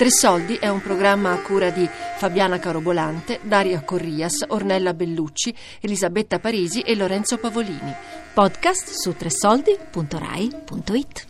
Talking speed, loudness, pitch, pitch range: 110 wpm, -21 LUFS, 195 Hz, 180-235 Hz